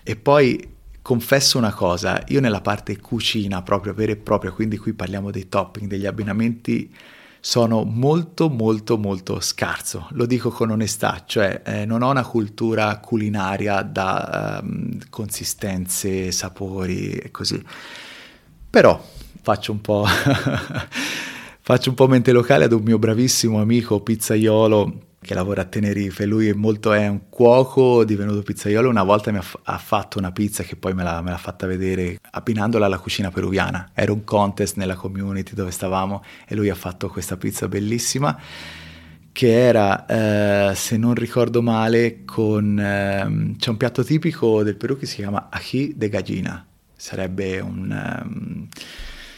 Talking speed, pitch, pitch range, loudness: 155 wpm, 105 Hz, 95-115 Hz, -20 LUFS